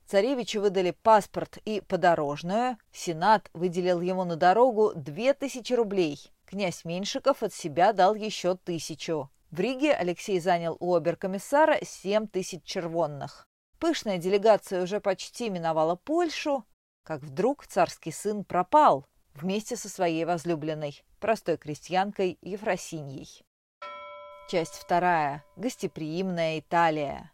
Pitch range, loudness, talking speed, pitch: 165-210 Hz, -27 LUFS, 110 wpm, 185 Hz